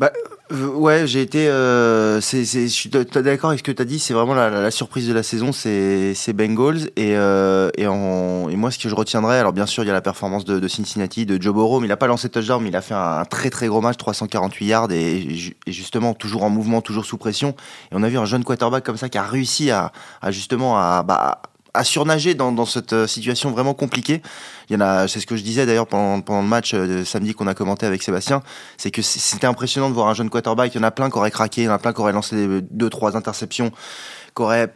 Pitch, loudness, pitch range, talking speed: 115 Hz, -19 LUFS, 105-125 Hz, 270 wpm